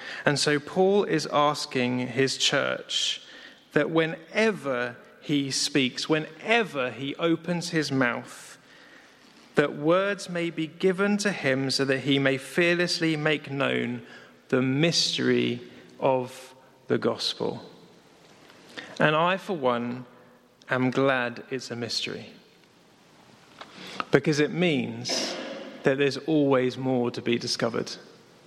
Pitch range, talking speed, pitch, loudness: 125-165 Hz, 115 wpm, 140 Hz, -26 LUFS